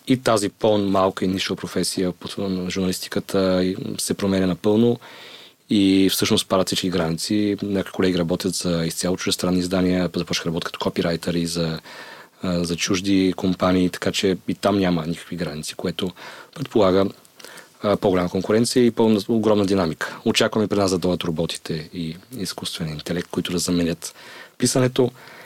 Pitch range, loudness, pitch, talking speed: 90-100 Hz, -22 LUFS, 95 Hz, 140 wpm